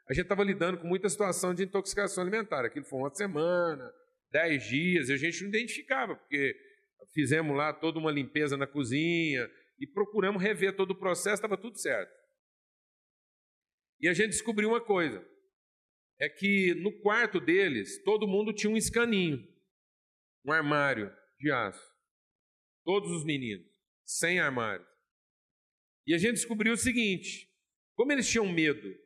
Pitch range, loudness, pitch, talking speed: 160-220 Hz, -30 LUFS, 195 Hz, 150 wpm